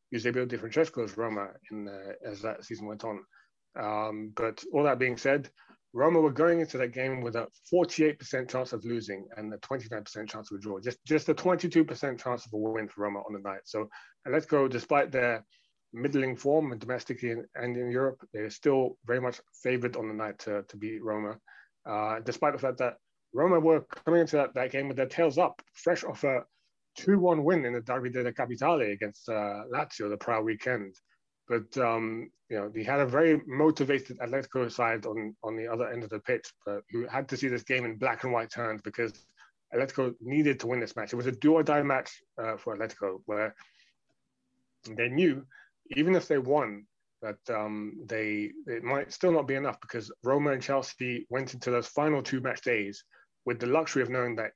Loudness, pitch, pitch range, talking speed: -30 LUFS, 125 Hz, 110-140 Hz, 205 wpm